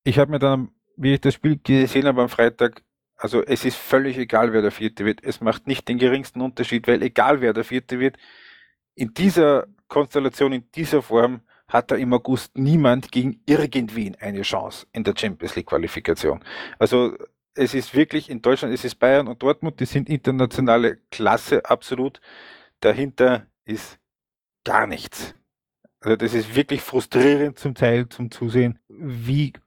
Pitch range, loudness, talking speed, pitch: 120-140 Hz, -21 LUFS, 170 wpm, 130 Hz